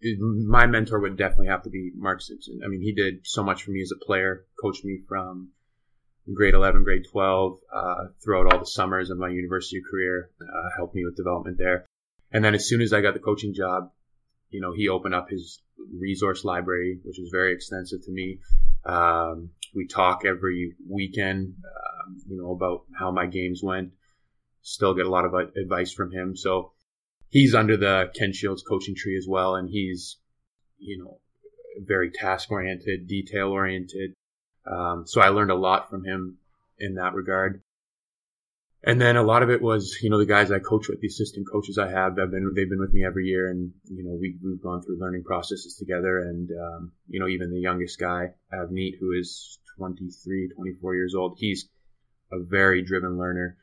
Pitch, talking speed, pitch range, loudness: 95 Hz, 190 wpm, 90-100 Hz, -25 LUFS